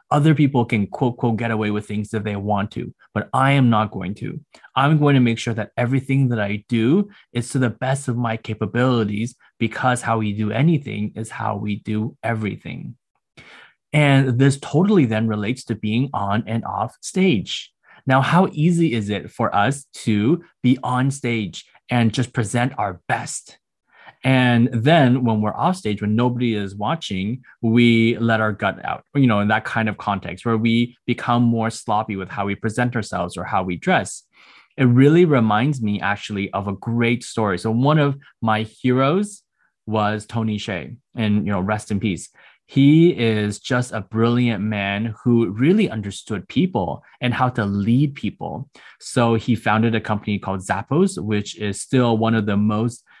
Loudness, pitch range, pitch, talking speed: -20 LUFS, 105-130 Hz, 115 Hz, 180 wpm